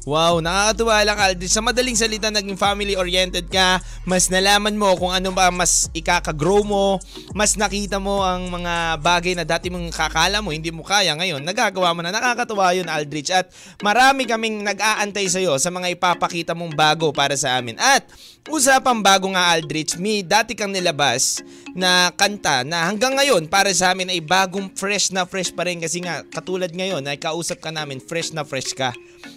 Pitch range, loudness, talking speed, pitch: 170-200 Hz, -19 LUFS, 185 wpm, 185 Hz